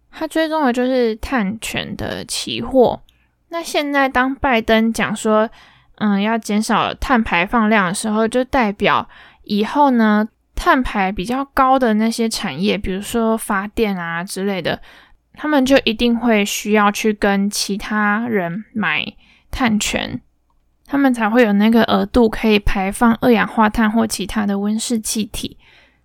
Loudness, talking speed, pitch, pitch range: -17 LUFS, 220 characters per minute, 220 Hz, 205-250 Hz